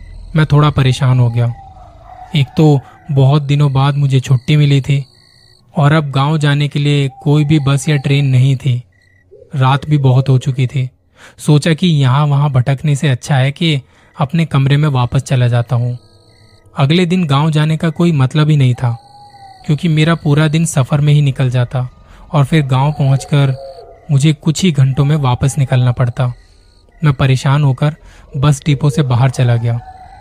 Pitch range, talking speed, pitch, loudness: 130-150 Hz, 175 wpm, 140 Hz, -13 LUFS